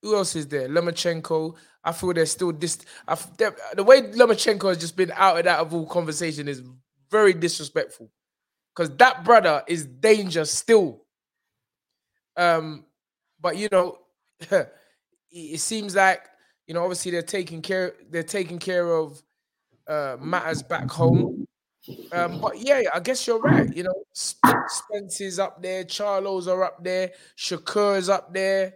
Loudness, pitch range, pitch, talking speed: -23 LUFS, 165-195 Hz, 180 Hz, 150 wpm